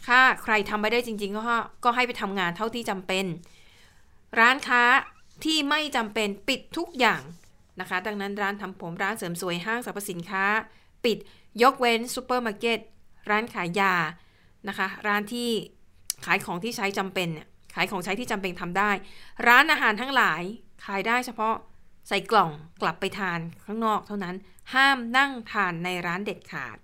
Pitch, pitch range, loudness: 205 Hz, 185-235 Hz, -25 LUFS